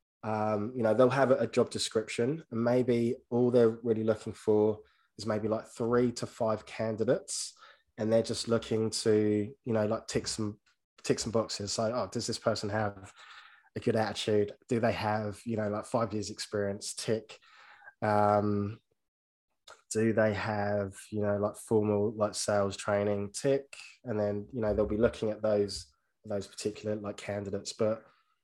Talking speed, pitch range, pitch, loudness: 170 wpm, 105-115 Hz, 110 Hz, -31 LUFS